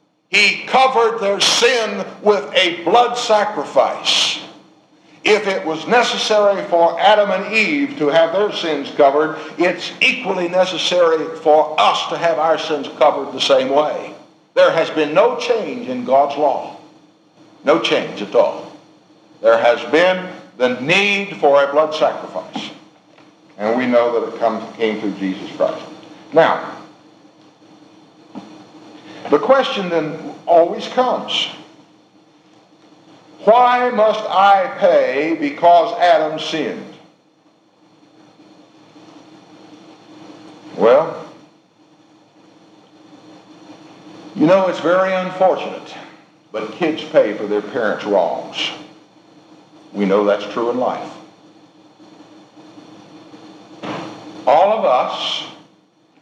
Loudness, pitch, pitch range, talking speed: -16 LUFS, 175 Hz, 150-210 Hz, 105 wpm